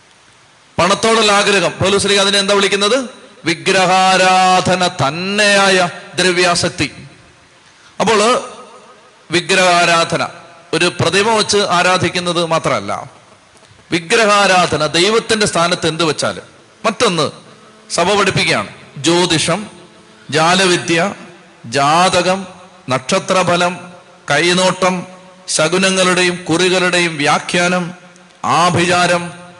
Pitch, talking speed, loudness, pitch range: 180 Hz, 60 wpm, -13 LUFS, 170-190 Hz